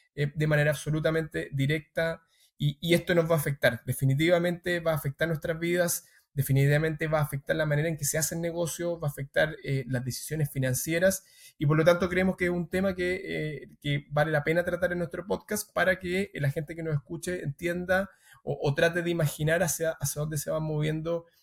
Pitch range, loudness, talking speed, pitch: 150-175 Hz, -28 LUFS, 205 wpm, 160 Hz